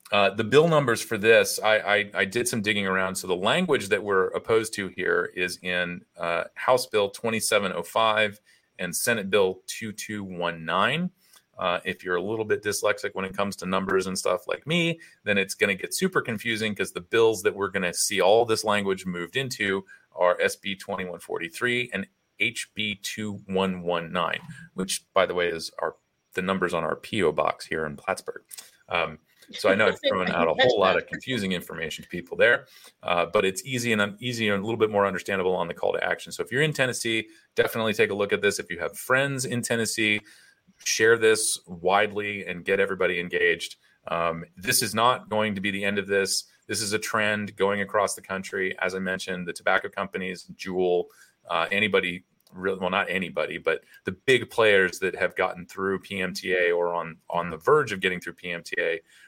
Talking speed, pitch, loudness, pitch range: 210 wpm, 105 Hz, -25 LUFS, 95-125 Hz